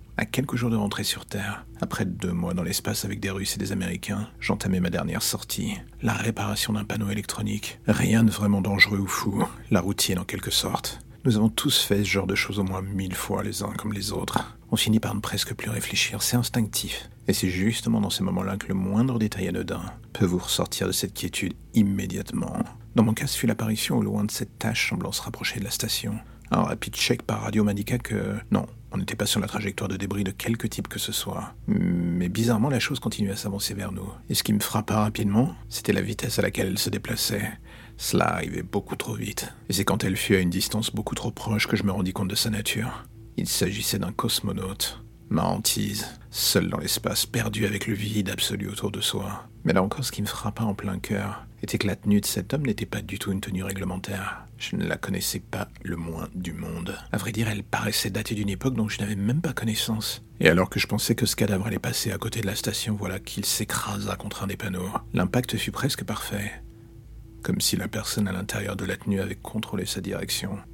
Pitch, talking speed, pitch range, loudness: 105 Hz, 230 wpm, 100-115 Hz, -26 LUFS